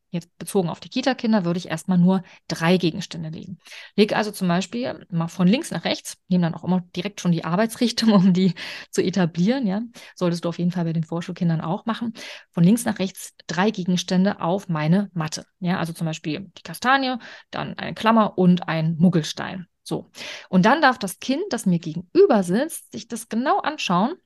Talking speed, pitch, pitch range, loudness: 195 wpm, 185 Hz, 175-215 Hz, -22 LUFS